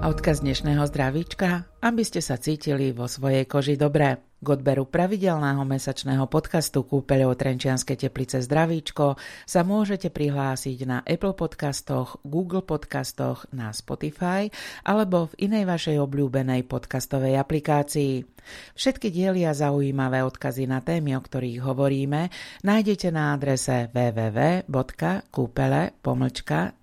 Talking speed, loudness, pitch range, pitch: 115 wpm, -25 LUFS, 135-165 Hz, 140 Hz